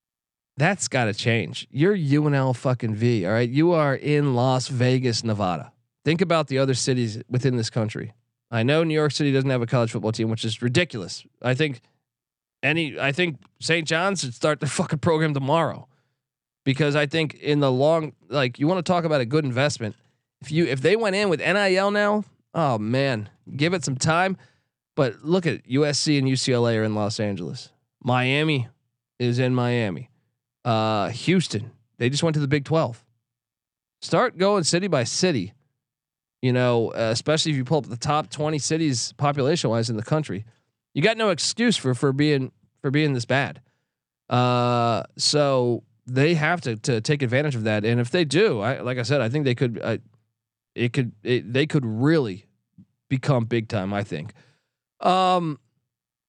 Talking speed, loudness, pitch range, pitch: 180 wpm, -23 LUFS, 120-150 Hz, 135 Hz